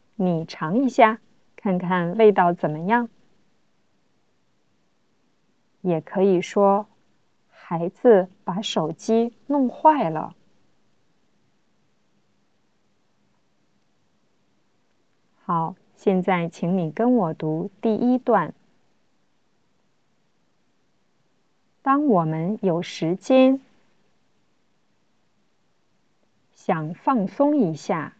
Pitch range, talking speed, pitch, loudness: 175-235 Hz, 95 characters per minute, 200 Hz, -22 LUFS